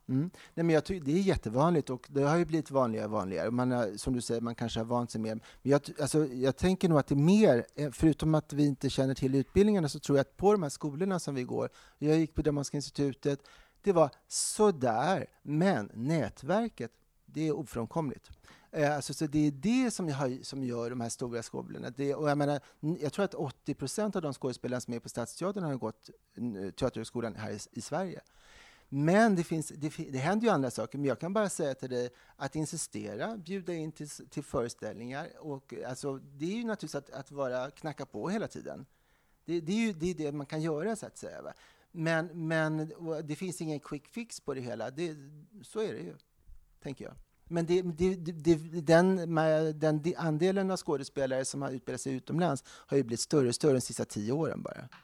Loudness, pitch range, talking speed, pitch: -32 LUFS, 130-170 Hz, 215 wpm, 150 Hz